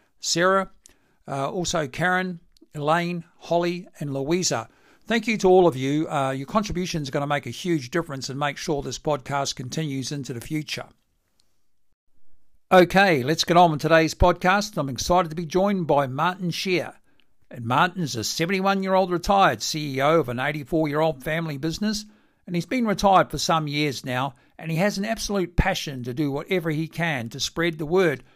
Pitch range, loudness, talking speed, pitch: 145-180 Hz, -23 LUFS, 180 wpm, 165 Hz